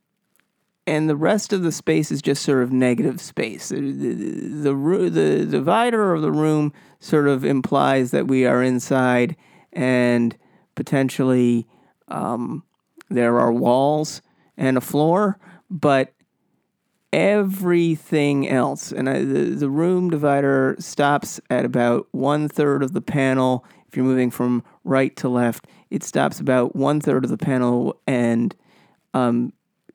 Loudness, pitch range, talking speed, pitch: -20 LUFS, 125-160 Hz, 140 wpm, 140 Hz